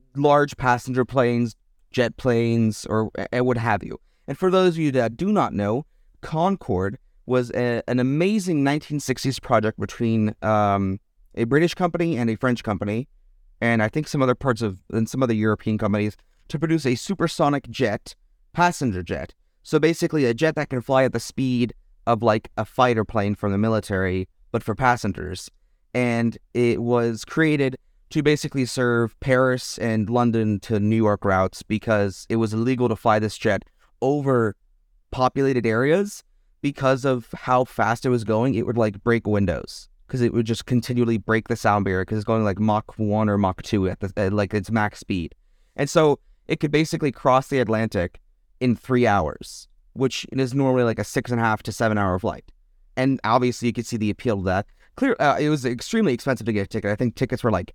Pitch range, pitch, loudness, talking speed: 105-130 Hz, 115 Hz, -22 LUFS, 185 wpm